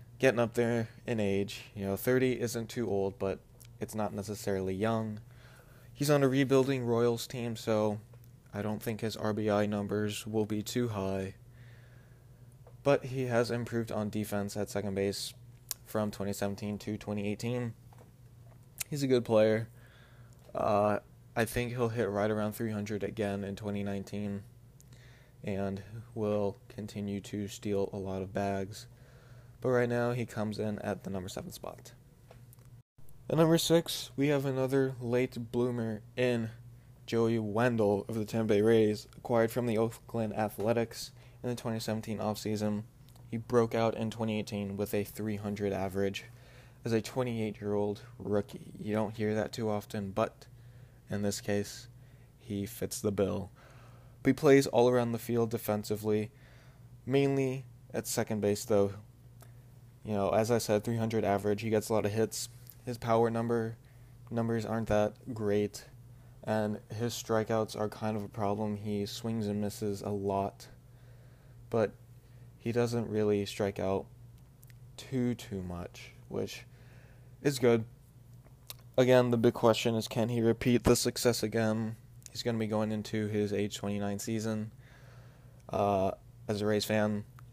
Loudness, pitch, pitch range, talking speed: -32 LUFS, 115 Hz, 105-125 Hz, 150 wpm